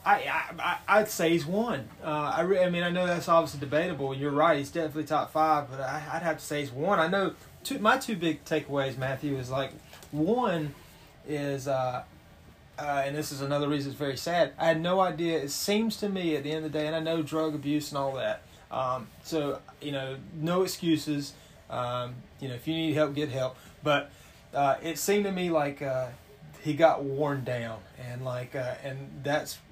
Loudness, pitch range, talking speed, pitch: -29 LUFS, 135-165 Hz, 215 wpm, 150 Hz